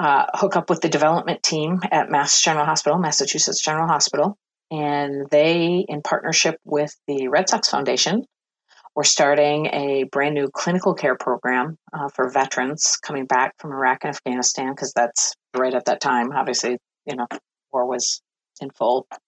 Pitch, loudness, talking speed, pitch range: 145 Hz, -20 LUFS, 160 wpm, 130-160 Hz